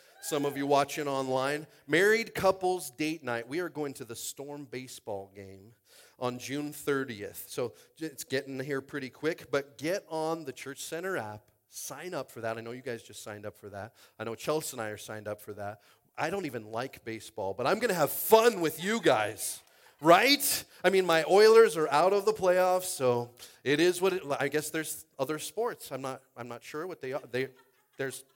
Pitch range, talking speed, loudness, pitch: 120-165 Hz, 210 wpm, -29 LUFS, 140 Hz